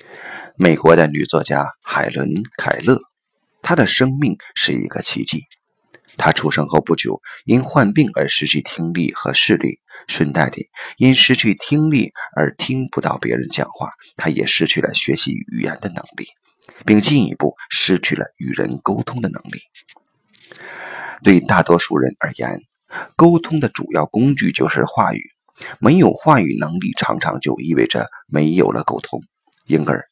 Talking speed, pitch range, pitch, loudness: 230 characters per minute, 80-130 Hz, 105 Hz, -16 LUFS